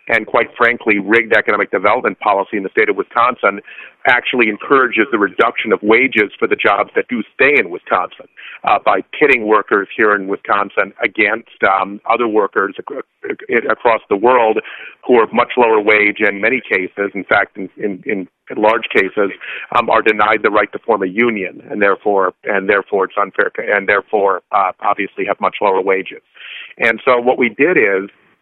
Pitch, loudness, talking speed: 115 Hz, -14 LUFS, 175 wpm